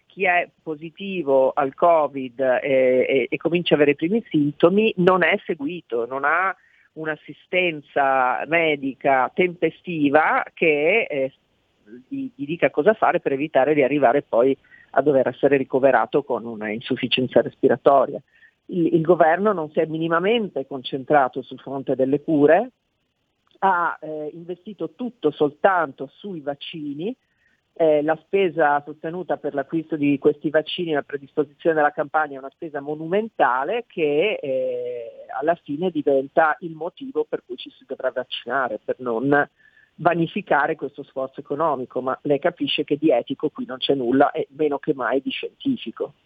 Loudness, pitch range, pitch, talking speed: -21 LUFS, 140-180 Hz, 155 Hz, 150 wpm